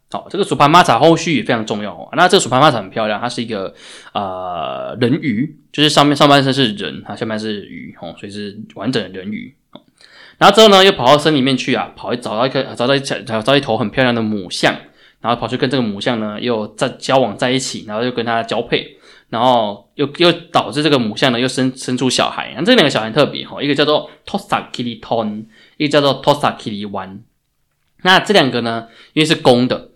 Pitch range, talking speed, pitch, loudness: 110-145 Hz, 365 characters per minute, 130 Hz, -15 LUFS